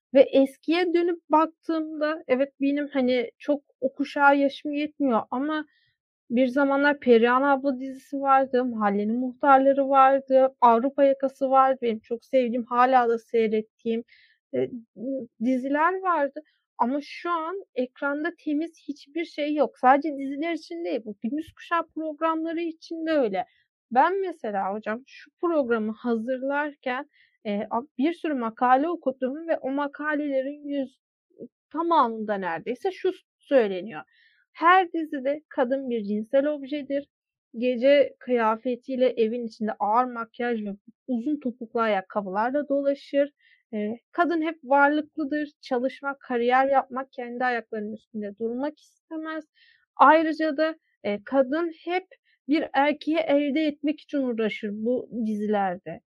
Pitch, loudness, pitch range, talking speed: 275 Hz, -25 LUFS, 240-305 Hz, 115 wpm